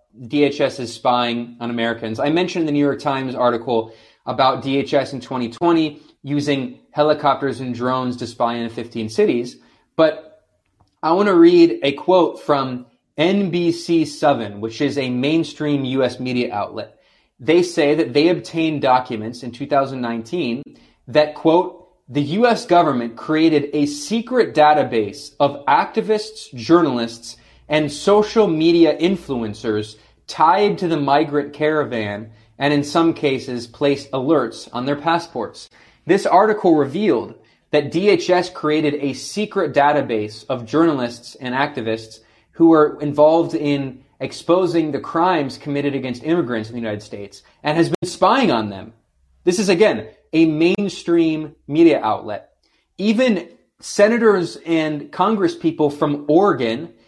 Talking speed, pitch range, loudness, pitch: 130 wpm, 120-165 Hz, -18 LUFS, 145 Hz